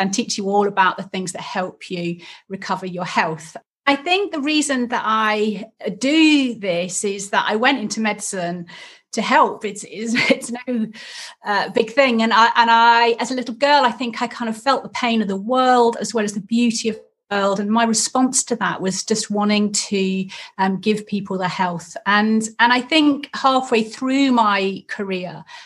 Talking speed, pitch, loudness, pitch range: 200 wpm, 220 Hz, -19 LUFS, 195-245 Hz